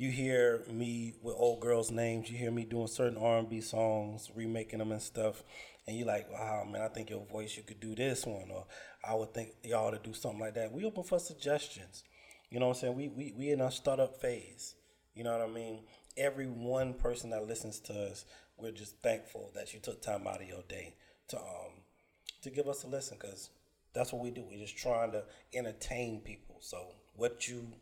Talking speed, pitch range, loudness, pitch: 225 wpm, 110-125 Hz, -38 LUFS, 115 Hz